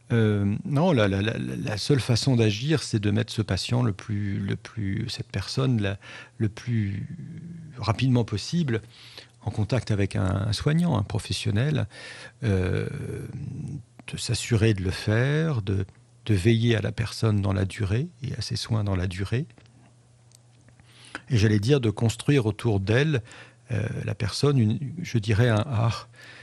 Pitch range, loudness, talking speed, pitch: 105-130 Hz, -26 LUFS, 160 wpm, 115 Hz